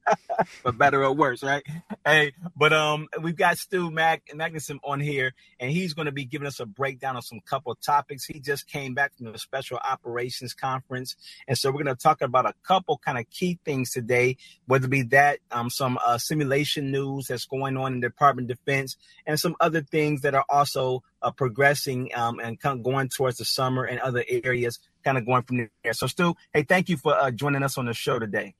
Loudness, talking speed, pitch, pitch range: -25 LUFS, 225 wpm, 135 Hz, 125-150 Hz